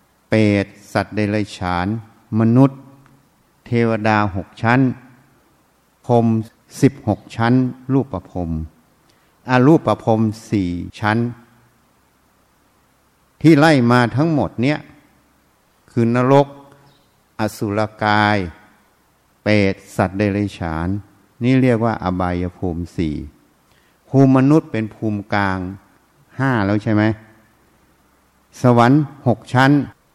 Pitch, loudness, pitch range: 110 Hz, -17 LUFS, 100-130 Hz